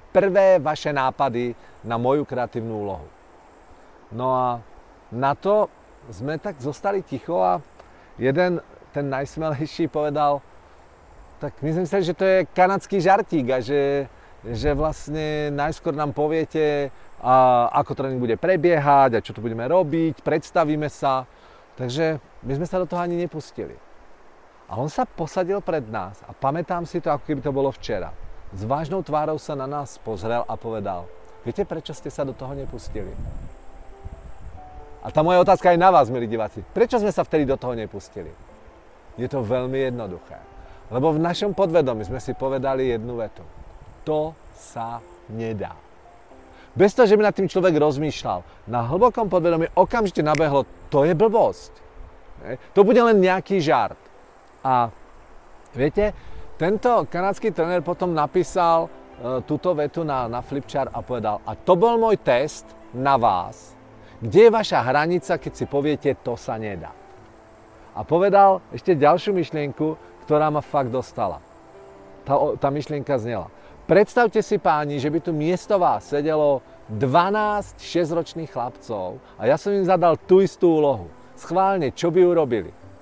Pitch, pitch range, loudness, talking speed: 145 Hz, 120-175 Hz, -22 LUFS, 150 wpm